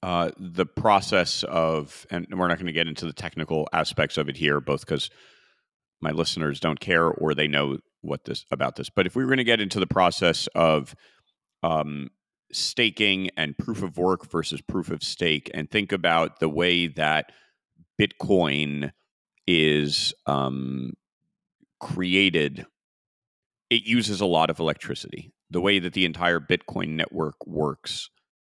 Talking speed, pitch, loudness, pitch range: 160 wpm, 85 Hz, -24 LUFS, 75-95 Hz